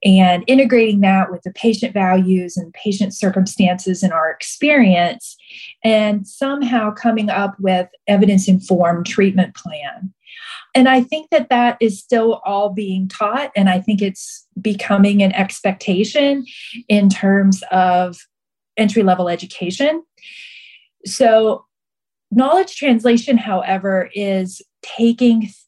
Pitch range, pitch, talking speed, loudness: 190-235 Hz, 200 Hz, 120 wpm, -16 LUFS